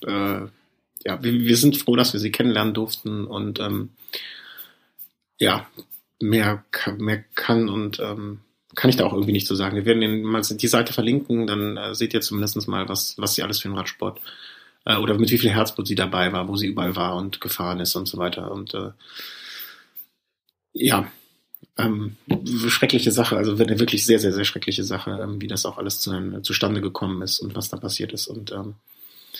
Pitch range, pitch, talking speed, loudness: 100-115 Hz, 105 Hz, 200 wpm, -22 LUFS